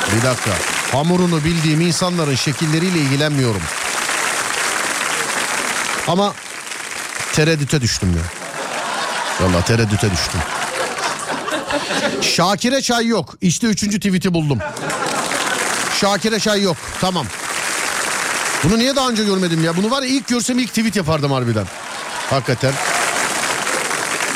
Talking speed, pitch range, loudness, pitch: 100 wpm, 125-200 Hz, -18 LUFS, 160 Hz